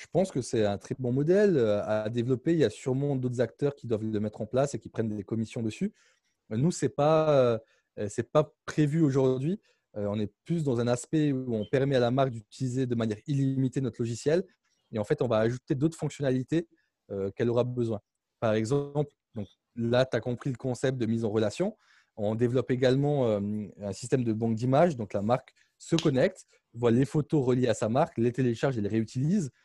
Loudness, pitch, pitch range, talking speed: -29 LUFS, 125 Hz, 110-145 Hz, 210 wpm